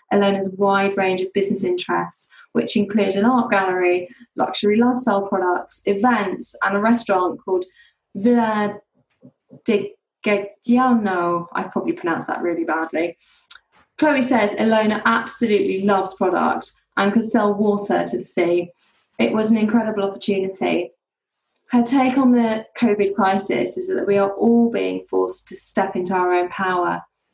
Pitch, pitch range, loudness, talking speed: 200 Hz, 185-230 Hz, -20 LUFS, 145 wpm